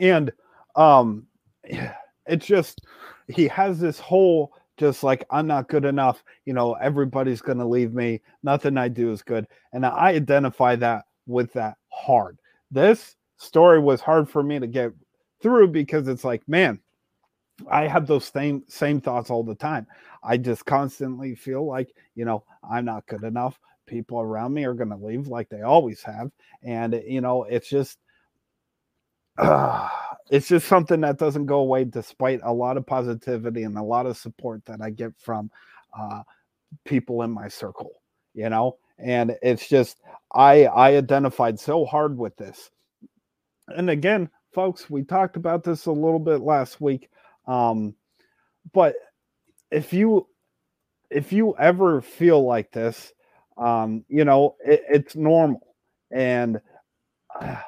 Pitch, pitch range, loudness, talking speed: 130 Hz, 120-150 Hz, -22 LUFS, 155 wpm